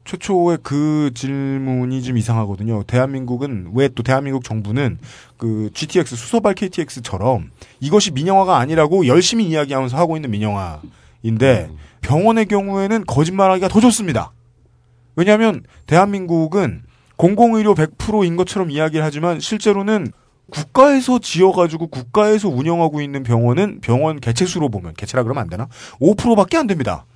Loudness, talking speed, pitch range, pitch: -17 LUFS, 355 characters per minute, 120-190 Hz, 150 Hz